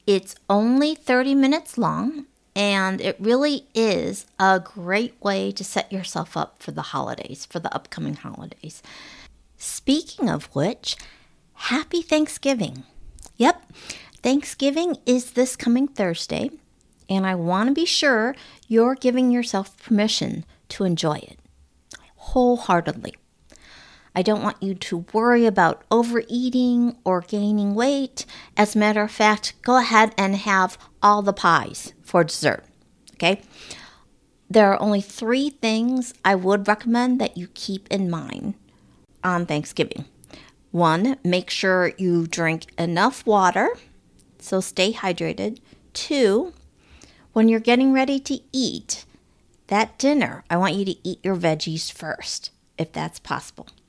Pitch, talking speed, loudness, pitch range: 215 Hz, 135 wpm, -22 LUFS, 190-250 Hz